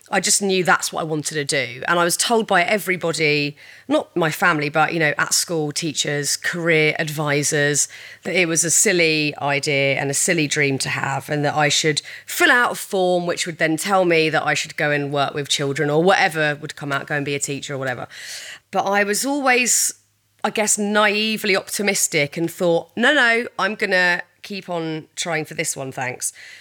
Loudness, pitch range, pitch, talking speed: -19 LUFS, 145-190 Hz, 165 Hz, 210 wpm